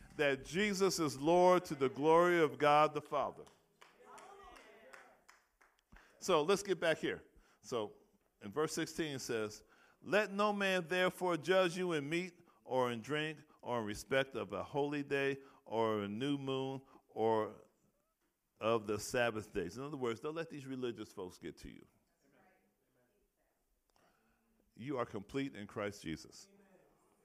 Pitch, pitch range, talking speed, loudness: 145 Hz, 120-170 Hz, 145 wpm, -36 LUFS